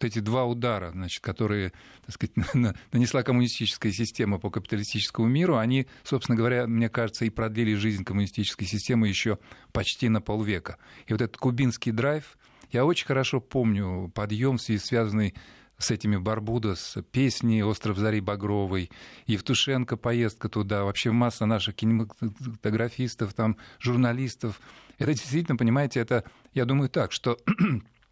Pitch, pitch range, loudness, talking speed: 115 Hz, 105-125 Hz, -27 LUFS, 135 wpm